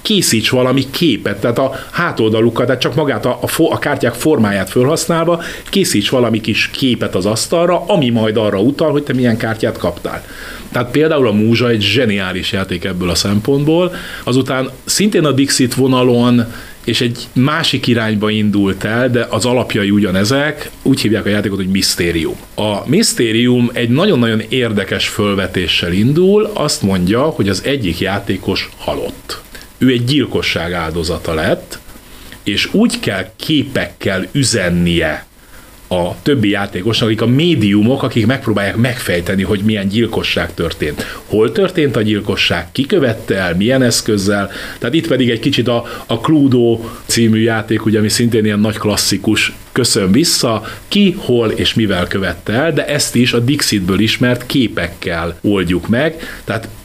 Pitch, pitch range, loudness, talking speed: 115 Hz, 105-135 Hz, -14 LUFS, 150 wpm